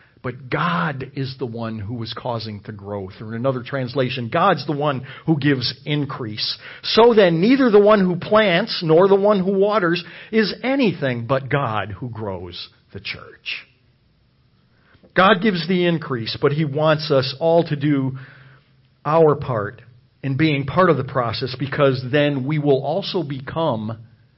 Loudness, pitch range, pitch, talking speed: -19 LUFS, 125-165 Hz, 140 Hz, 160 wpm